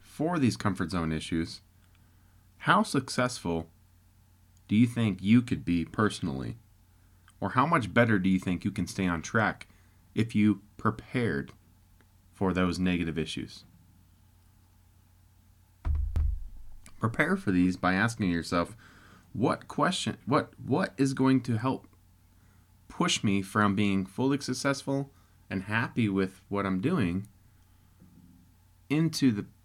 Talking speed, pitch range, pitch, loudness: 125 wpm, 90-110 Hz, 95 Hz, -29 LUFS